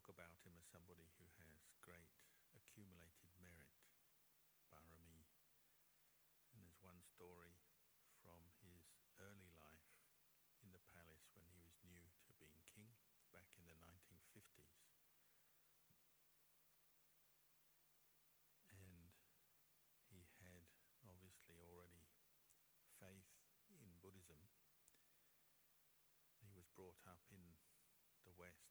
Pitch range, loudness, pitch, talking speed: 80-95 Hz, -68 LUFS, 85 Hz, 100 wpm